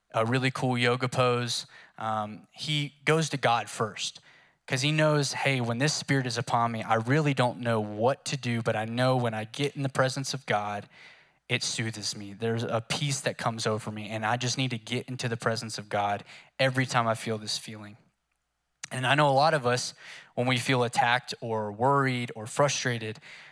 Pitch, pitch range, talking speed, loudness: 125 Hz, 115-135 Hz, 205 wpm, -28 LUFS